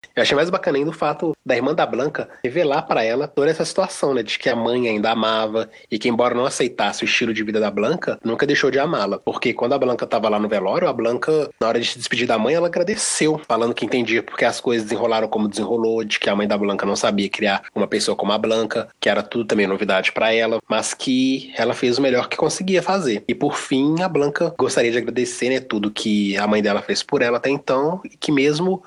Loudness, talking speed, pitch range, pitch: -20 LUFS, 245 wpm, 110-145 Hz, 115 Hz